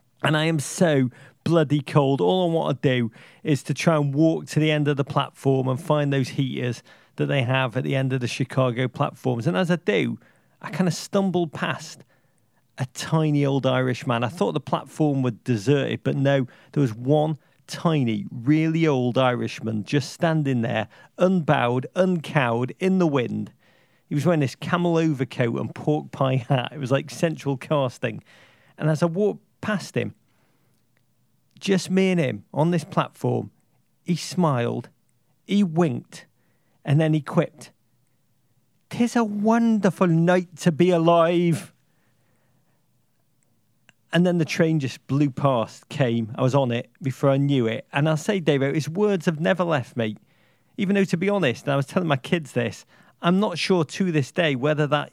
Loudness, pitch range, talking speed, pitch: -23 LUFS, 130-170 Hz, 175 wpm, 145 Hz